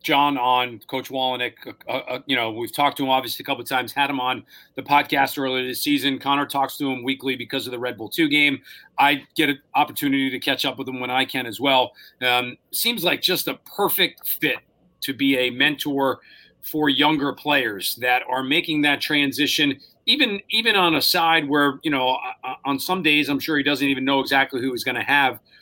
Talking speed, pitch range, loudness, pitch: 220 wpm, 130-145 Hz, -21 LUFS, 135 Hz